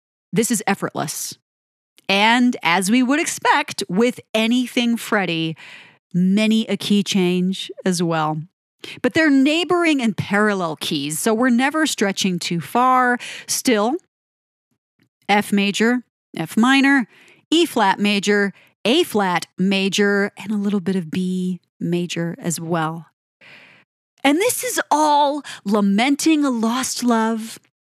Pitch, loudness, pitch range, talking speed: 205 Hz, -19 LUFS, 180-250 Hz, 125 wpm